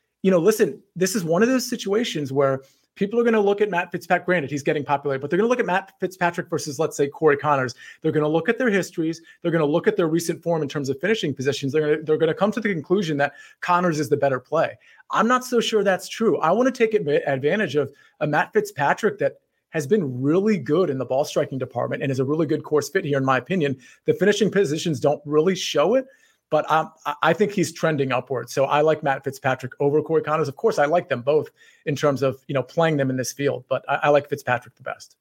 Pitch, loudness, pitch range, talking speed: 160 Hz, -22 LUFS, 145-195 Hz, 260 wpm